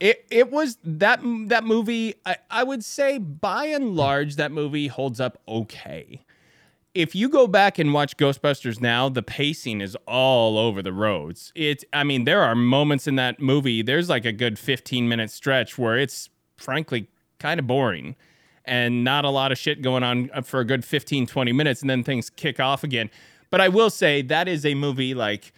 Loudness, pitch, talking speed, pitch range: -22 LUFS, 140 Hz, 195 wpm, 125-165 Hz